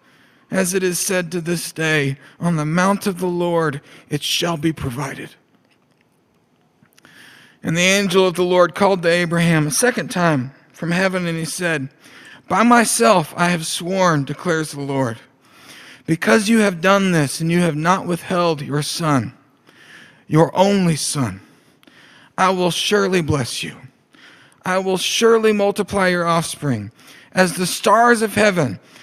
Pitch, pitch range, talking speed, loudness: 175 Hz, 155-190 Hz, 150 wpm, -18 LUFS